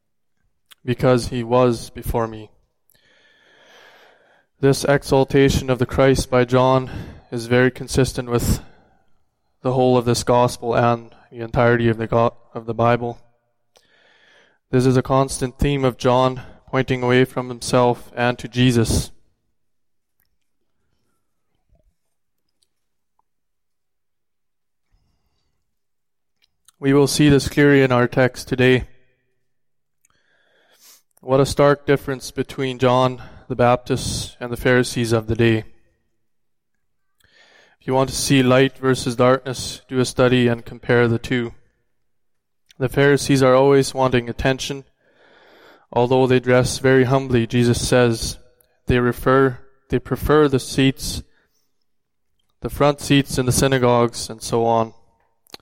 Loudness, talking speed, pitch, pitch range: -18 LUFS, 120 wpm, 125 Hz, 120-130 Hz